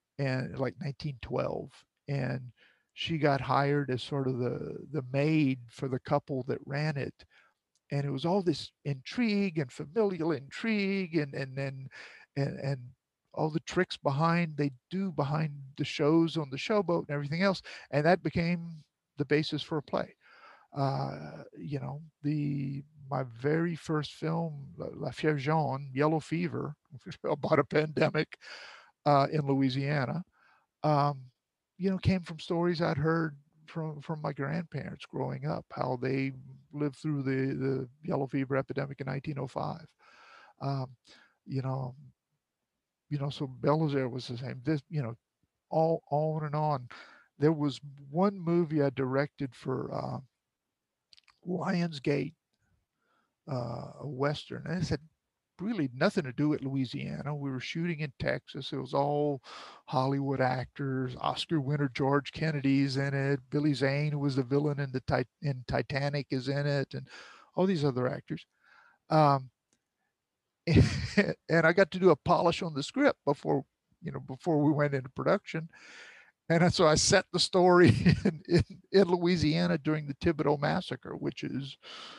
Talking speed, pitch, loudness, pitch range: 150 wpm, 145 Hz, -31 LUFS, 135-165 Hz